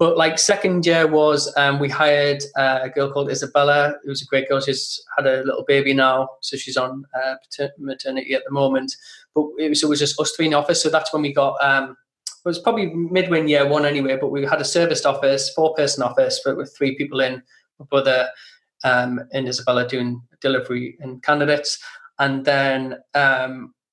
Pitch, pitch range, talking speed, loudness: 140 Hz, 135-150 Hz, 200 wpm, -20 LUFS